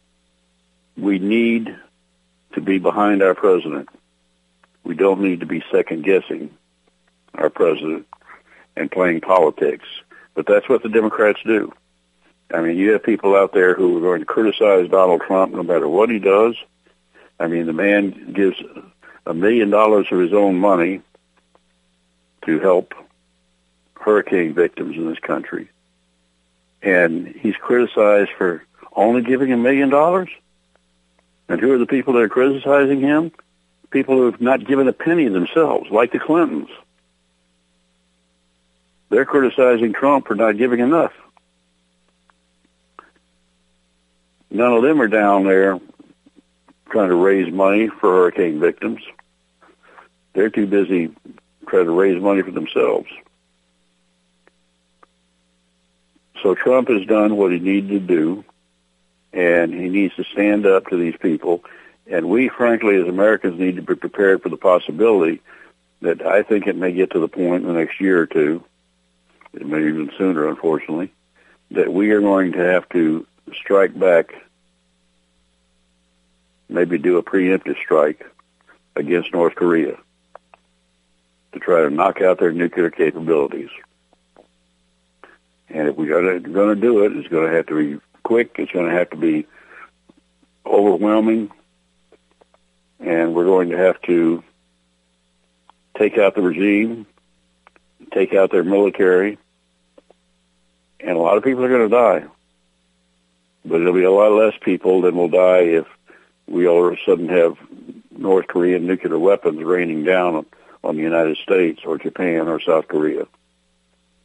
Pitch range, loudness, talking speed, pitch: 60-100 Hz, -17 LUFS, 145 wpm, 80 Hz